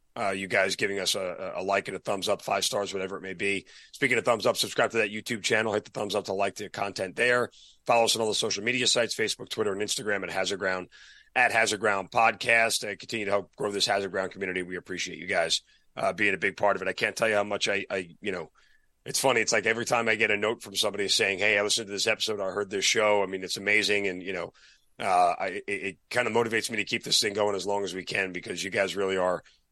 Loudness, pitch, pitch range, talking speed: -27 LUFS, 100 Hz, 95-110 Hz, 280 wpm